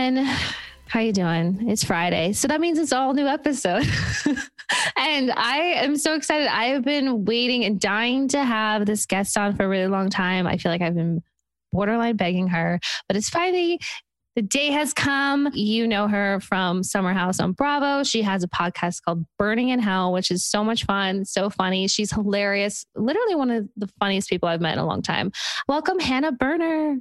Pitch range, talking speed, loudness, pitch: 190-275 Hz, 195 wpm, -22 LUFS, 210 Hz